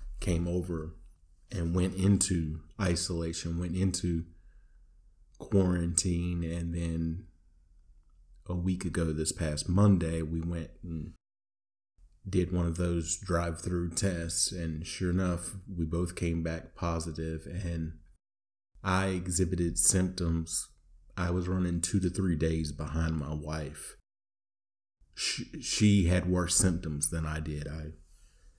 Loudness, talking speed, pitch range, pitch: -31 LUFS, 120 wpm, 80-90 Hz, 85 Hz